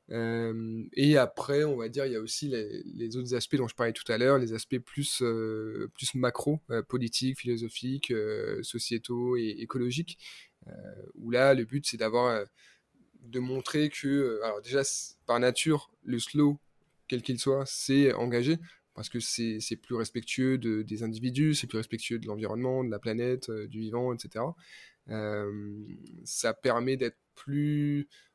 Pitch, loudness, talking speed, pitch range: 125 Hz, -30 LUFS, 175 wpm, 115-140 Hz